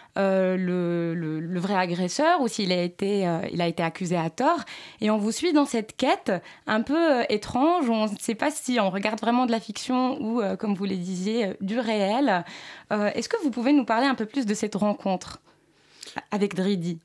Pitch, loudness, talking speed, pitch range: 215 Hz, -25 LUFS, 225 wpm, 185-250 Hz